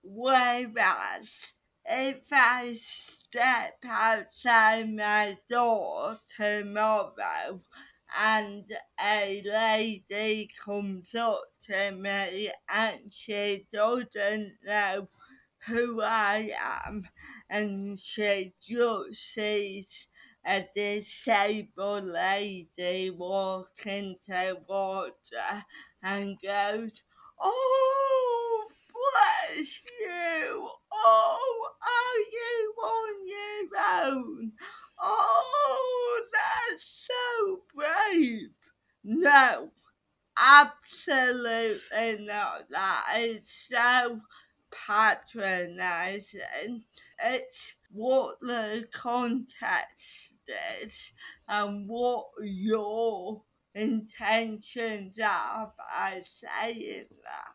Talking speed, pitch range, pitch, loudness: 70 wpm, 205-280 Hz, 220 Hz, -28 LUFS